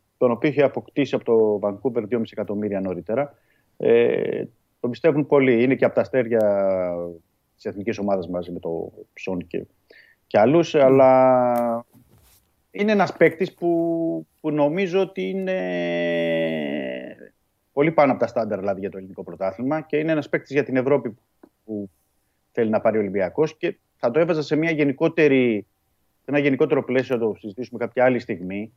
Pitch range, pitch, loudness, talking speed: 100-145 Hz, 120 Hz, -22 LUFS, 165 wpm